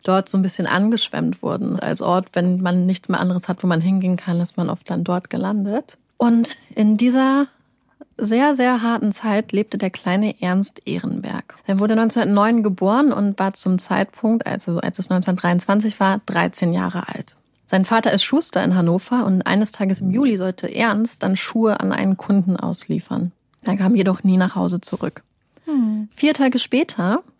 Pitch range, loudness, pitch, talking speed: 185-230 Hz, -19 LUFS, 200 Hz, 175 wpm